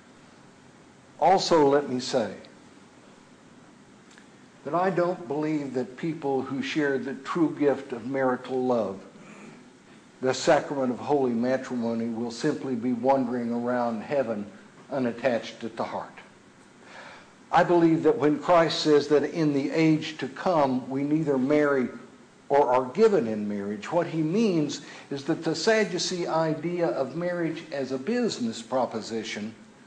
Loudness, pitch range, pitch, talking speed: -26 LUFS, 125-160 Hz, 140 Hz, 135 wpm